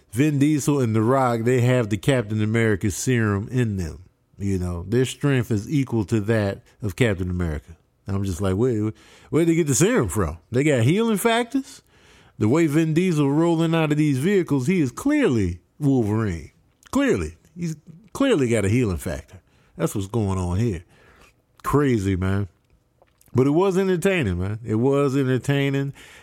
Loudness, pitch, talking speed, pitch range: -22 LUFS, 125 Hz, 165 wpm, 100-150 Hz